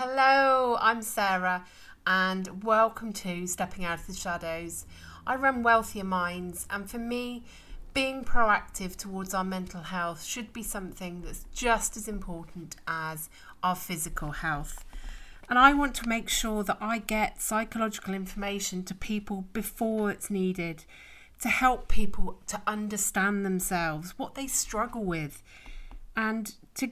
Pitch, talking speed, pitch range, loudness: 200 Hz, 140 wpm, 180-225 Hz, -29 LUFS